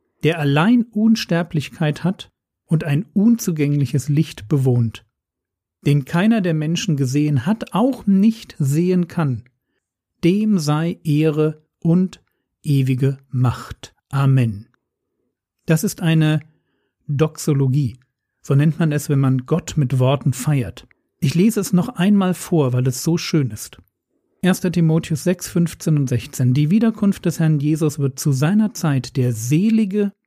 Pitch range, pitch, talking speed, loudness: 135-180 Hz, 155 Hz, 135 wpm, -19 LUFS